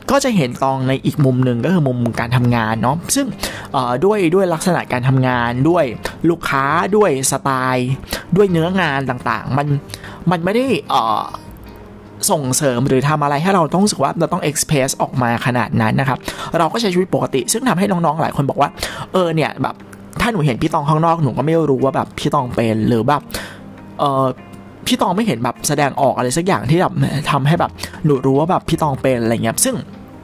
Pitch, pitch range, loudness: 140 Hz, 125-170 Hz, -17 LUFS